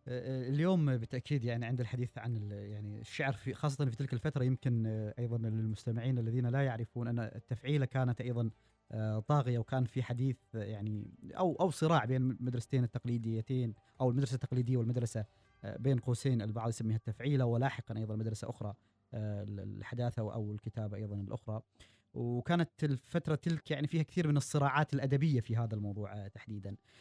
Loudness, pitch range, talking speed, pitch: -36 LUFS, 110-135 Hz, 145 wpm, 120 Hz